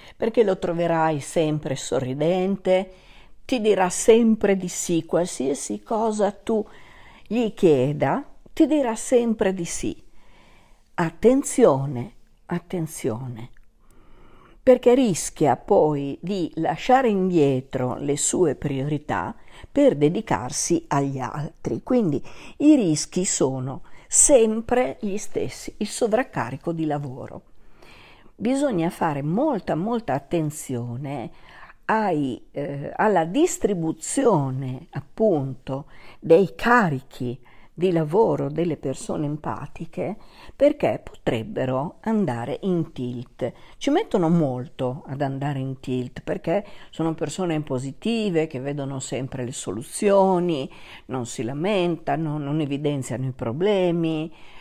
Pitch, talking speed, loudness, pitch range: 160 Hz, 100 wpm, -23 LUFS, 135-205 Hz